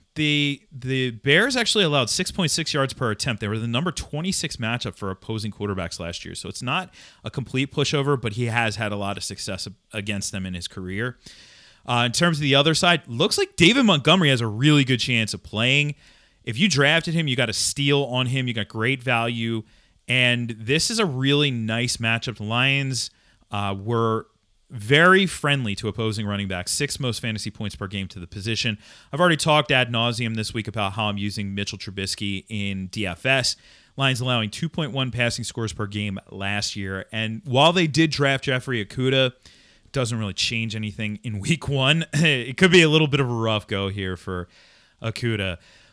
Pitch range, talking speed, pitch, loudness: 105-140 Hz, 195 wpm, 120 Hz, -22 LUFS